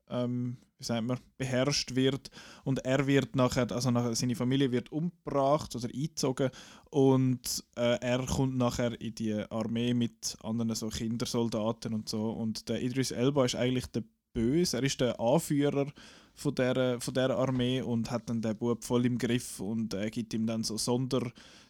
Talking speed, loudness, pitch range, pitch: 180 wpm, -31 LUFS, 115-130 Hz, 125 Hz